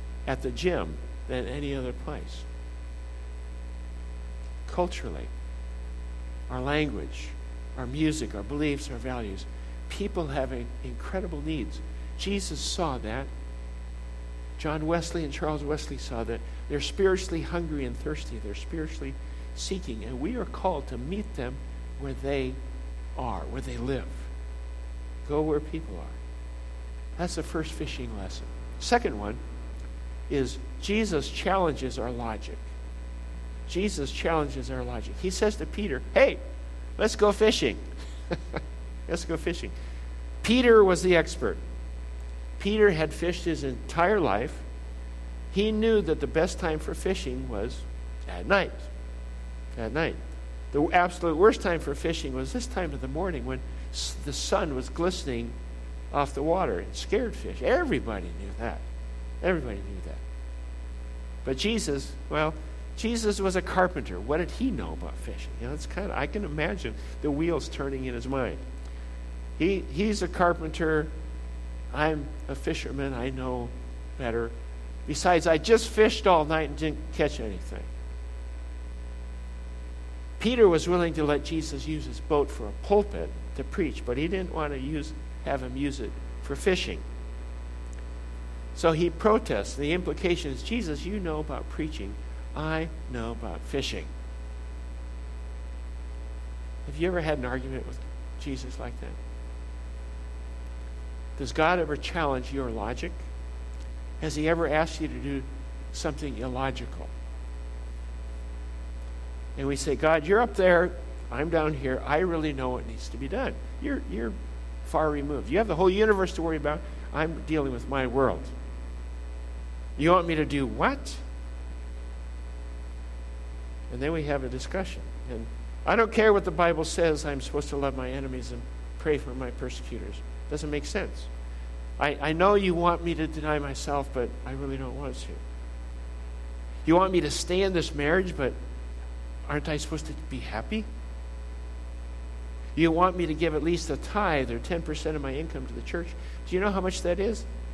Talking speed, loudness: 150 wpm, -29 LUFS